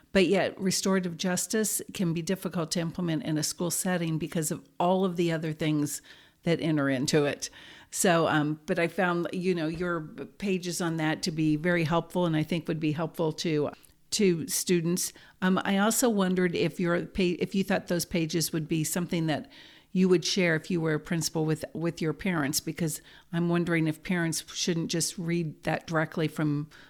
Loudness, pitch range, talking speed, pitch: -28 LUFS, 160-180 Hz, 195 wpm, 170 Hz